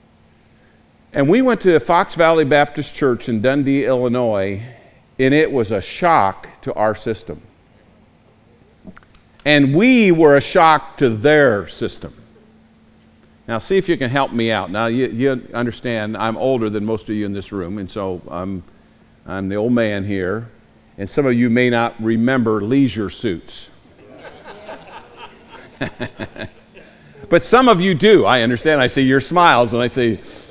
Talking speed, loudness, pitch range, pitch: 155 wpm, -16 LUFS, 110-140 Hz, 120 Hz